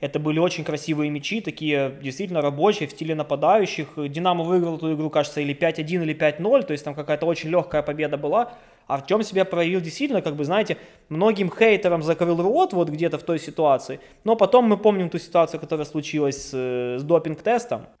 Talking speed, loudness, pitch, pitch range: 190 wpm, -23 LUFS, 160 Hz, 150-185 Hz